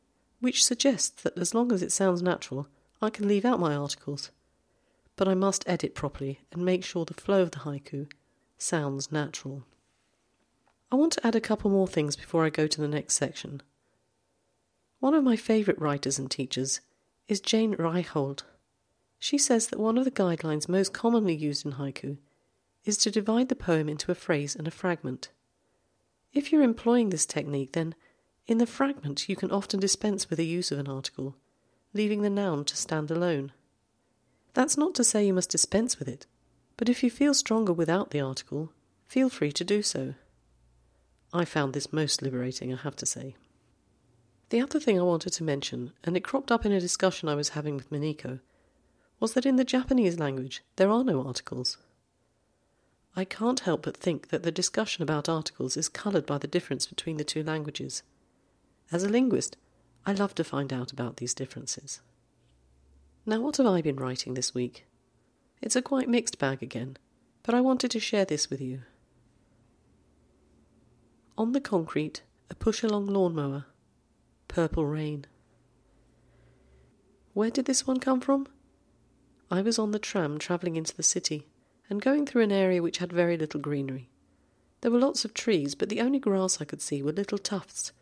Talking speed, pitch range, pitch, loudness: 180 wpm, 140-210 Hz, 165 Hz, -28 LUFS